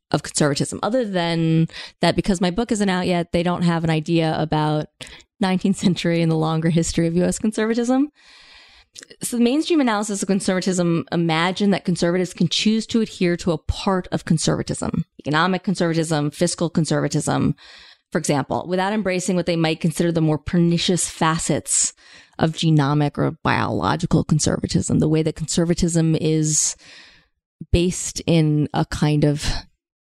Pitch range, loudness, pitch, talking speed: 160-190 Hz, -20 LUFS, 170 Hz, 150 wpm